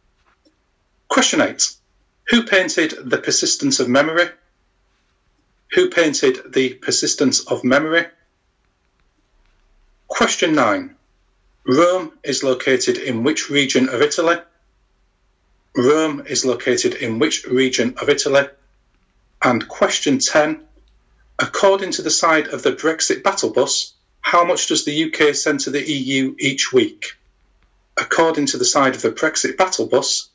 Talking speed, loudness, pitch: 125 wpm, -17 LUFS, 165 Hz